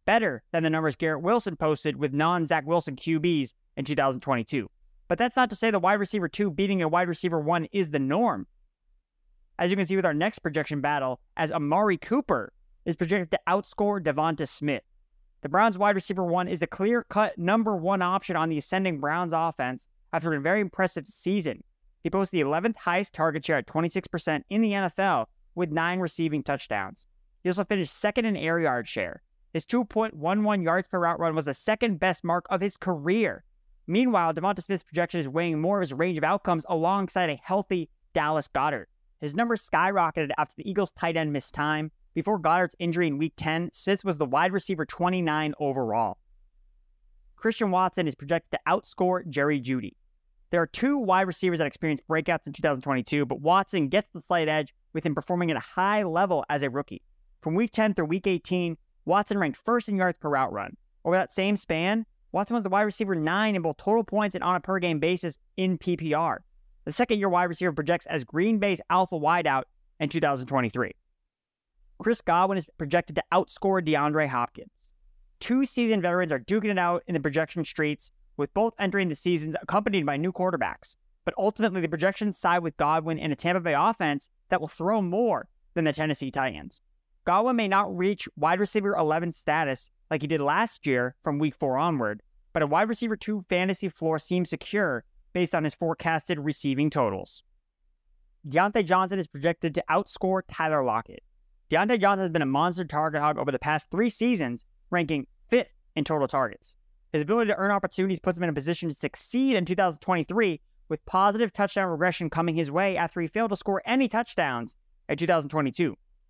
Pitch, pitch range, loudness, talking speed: 175 Hz, 155-195 Hz, -27 LUFS, 190 wpm